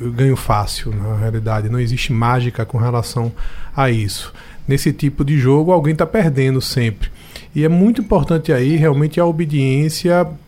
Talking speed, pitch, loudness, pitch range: 160 wpm, 135 Hz, -16 LUFS, 115-160 Hz